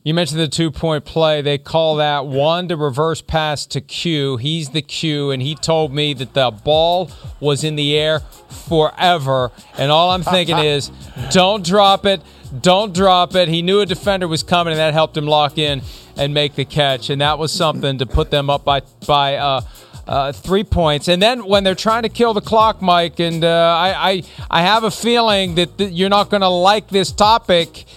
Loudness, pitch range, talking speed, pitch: -16 LUFS, 145-185 Hz, 205 wpm, 160 Hz